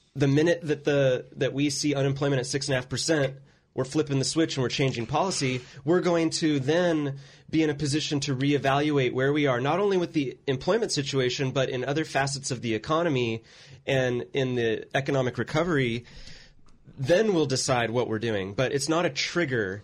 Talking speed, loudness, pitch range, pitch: 180 wpm, -26 LUFS, 130-155 Hz, 140 Hz